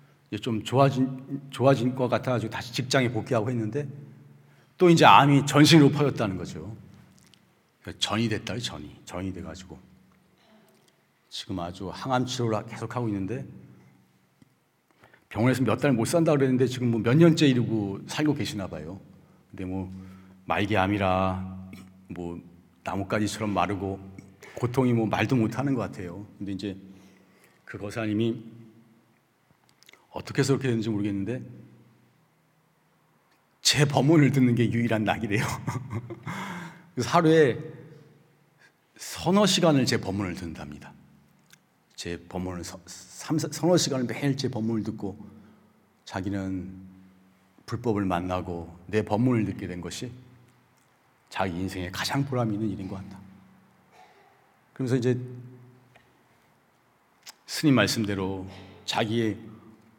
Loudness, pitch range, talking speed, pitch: -26 LUFS, 95-130 Hz, 250 characters per minute, 115 Hz